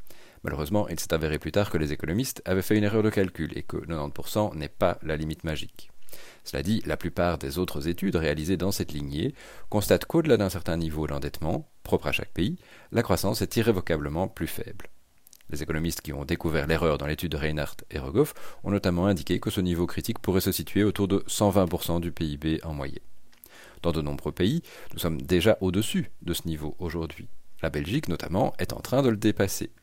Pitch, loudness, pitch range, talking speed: 85 Hz, -28 LUFS, 80-100 Hz, 200 wpm